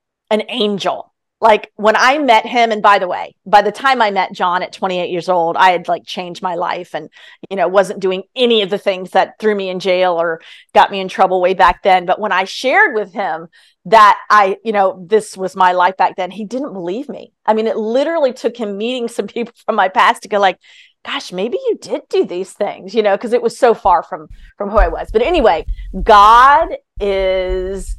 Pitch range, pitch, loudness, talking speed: 185-225 Hz, 205 Hz, -14 LUFS, 230 wpm